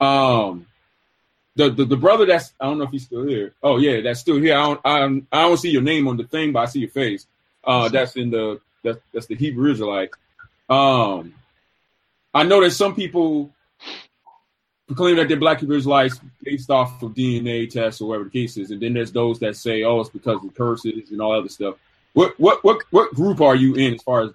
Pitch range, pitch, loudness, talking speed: 115-145 Hz, 130 Hz, -19 LUFS, 230 wpm